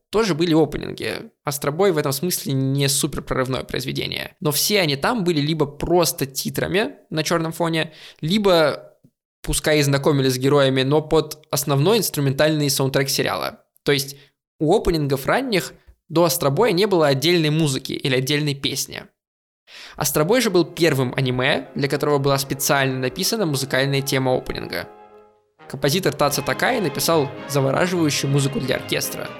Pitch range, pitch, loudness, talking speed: 135-165 Hz, 145 Hz, -20 LUFS, 140 wpm